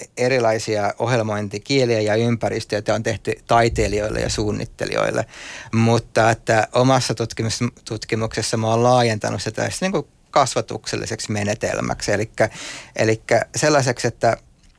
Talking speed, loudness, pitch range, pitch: 95 wpm, -20 LUFS, 110-120 Hz, 115 Hz